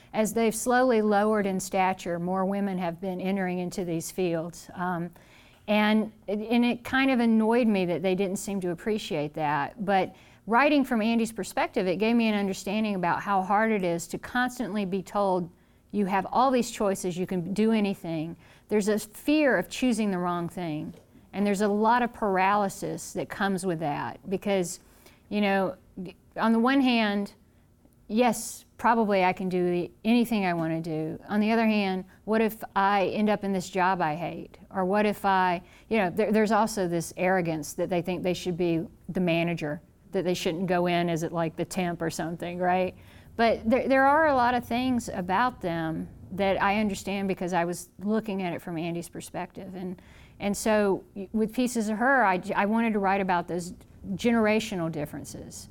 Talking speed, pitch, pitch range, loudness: 190 wpm, 195 Hz, 180-215 Hz, -27 LUFS